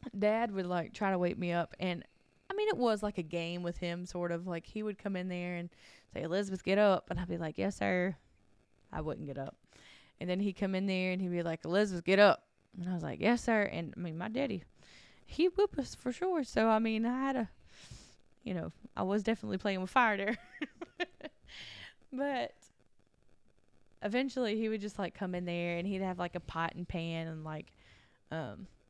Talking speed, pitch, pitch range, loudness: 220 wpm, 190 Hz, 175-225 Hz, -35 LUFS